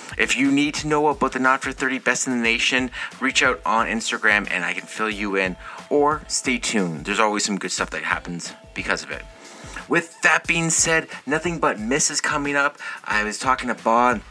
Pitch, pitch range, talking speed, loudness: 130 Hz, 105-150 Hz, 220 wpm, -21 LUFS